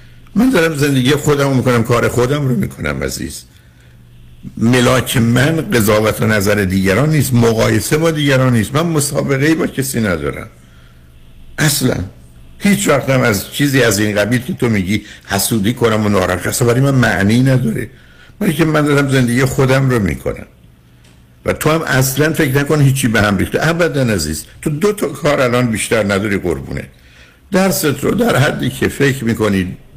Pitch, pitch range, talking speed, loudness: 120 Hz, 95-140 Hz, 170 wpm, -14 LUFS